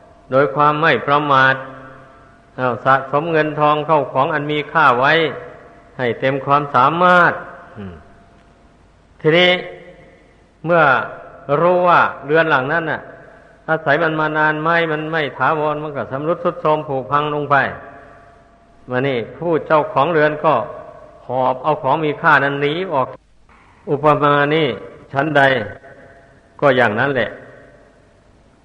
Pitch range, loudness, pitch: 130-155 Hz, -16 LUFS, 145 Hz